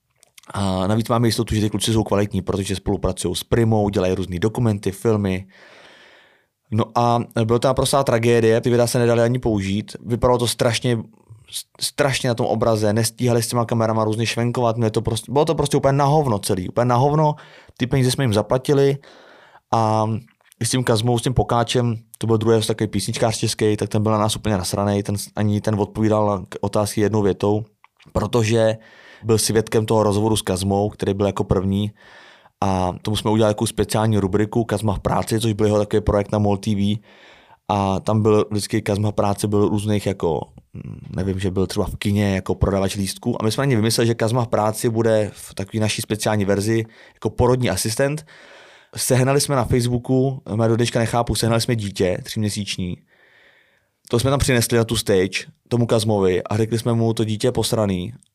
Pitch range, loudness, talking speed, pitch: 105-120 Hz, -20 LUFS, 190 wpm, 110 Hz